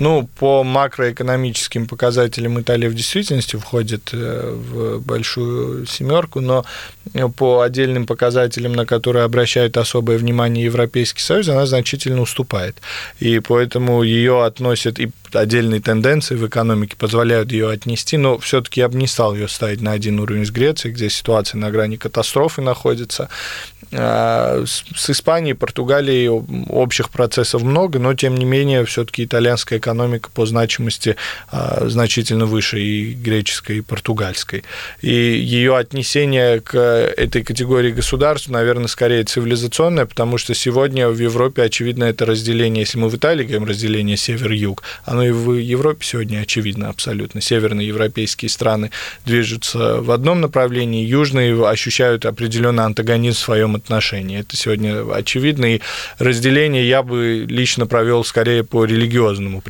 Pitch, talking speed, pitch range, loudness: 120 Hz, 140 wpm, 110-125 Hz, -17 LUFS